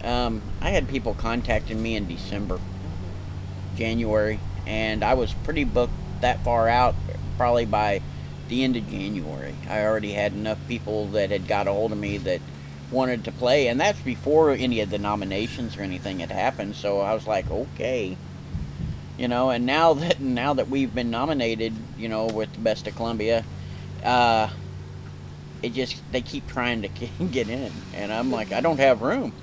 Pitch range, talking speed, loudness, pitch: 95-120 Hz, 180 wpm, -25 LUFS, 110 Hz